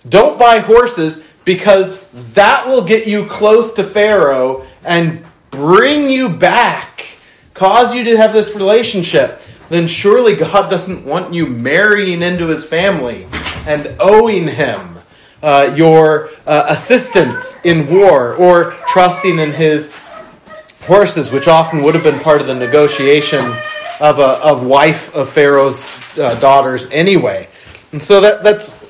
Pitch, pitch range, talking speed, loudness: 170 Hz, 150-210 Hz, 140 wpm, -10 LUFS